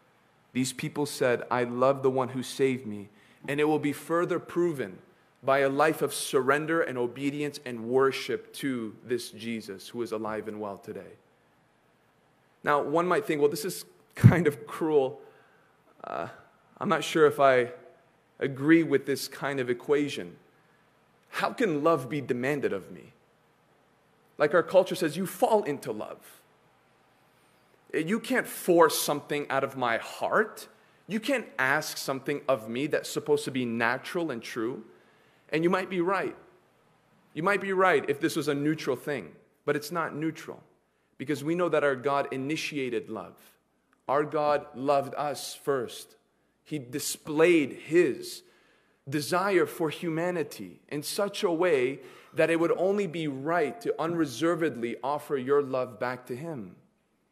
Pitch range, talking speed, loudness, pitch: 135-170 Hz, 155 wpm, -28 LUFS, 150 Hz